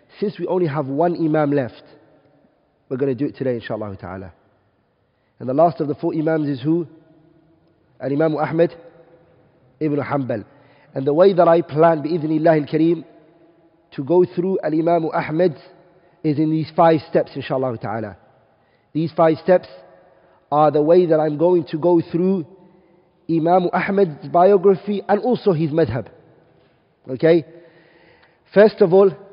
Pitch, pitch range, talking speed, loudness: 160 Hz, 145-175 Hz, 145 wpm, -18 LUFS